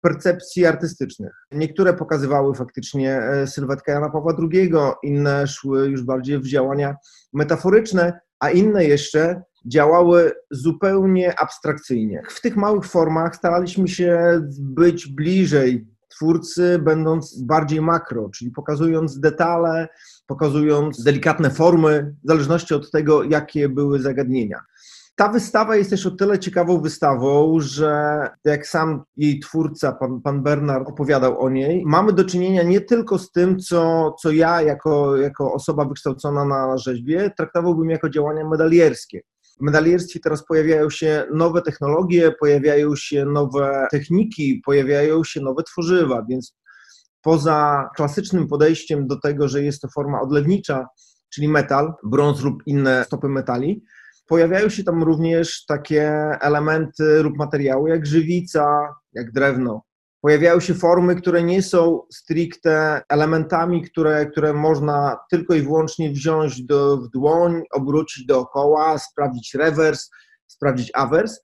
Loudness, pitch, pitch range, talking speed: -19 LUFS, 155 Hz, 140-170 Hz, 130 wpm